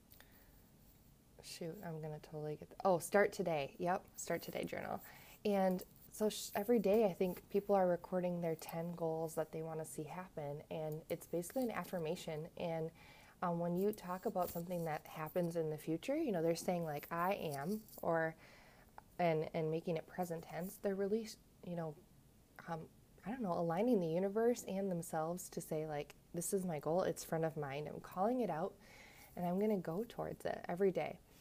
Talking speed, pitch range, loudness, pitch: 185 wpm, 160-195 Hz, -40 LUFS, 175 Hz